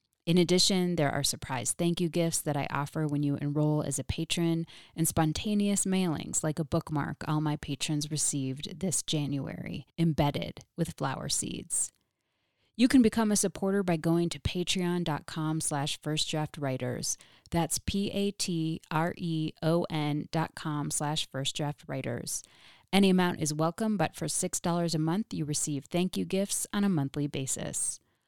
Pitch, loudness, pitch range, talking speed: 160 Hz, -30 LUFS, 150-175 Hz, 160 wpm